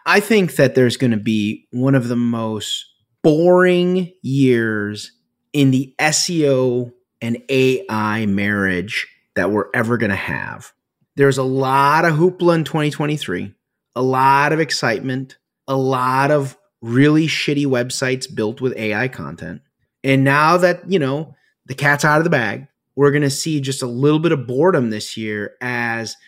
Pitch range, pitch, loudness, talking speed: 115-150 Hz, 130 Hz, -17 LUFS, 160 wpm